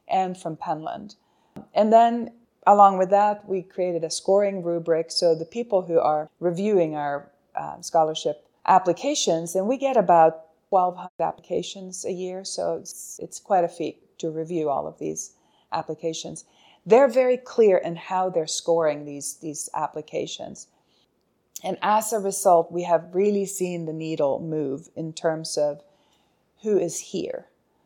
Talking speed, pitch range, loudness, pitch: 150 wpm, 160-195 Hz, -23 LUFS, 170 Hz